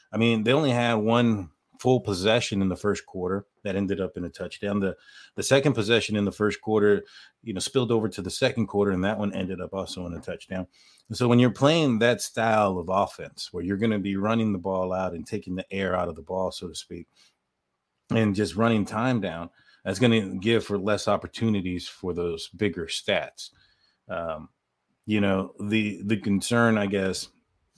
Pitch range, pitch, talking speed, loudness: 95-115 Hz, 100 Hz, 205 wpm, -26 LUFS